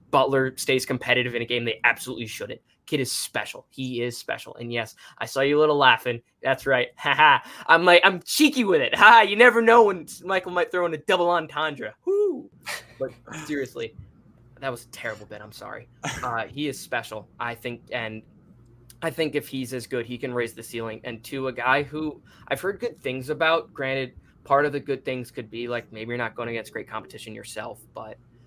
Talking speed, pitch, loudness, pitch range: 210 wpm, 130 Hz, -23 LUFS, 120-160 Hz